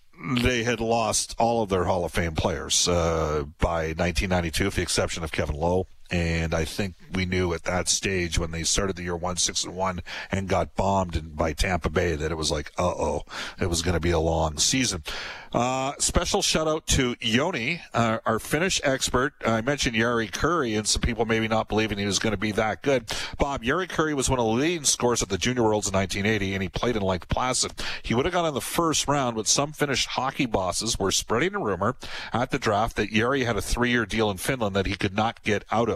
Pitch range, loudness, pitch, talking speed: 90-120 Hz, -25 LUFS, 100 Hz, 230 wpm